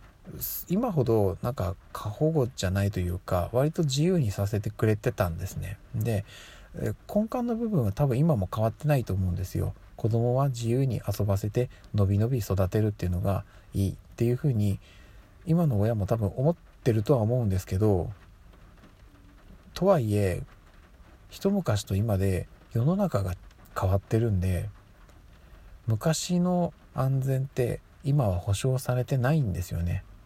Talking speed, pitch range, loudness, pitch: 295 characters per minute, 95-130 Hz, -28 LUFS, 105 Hz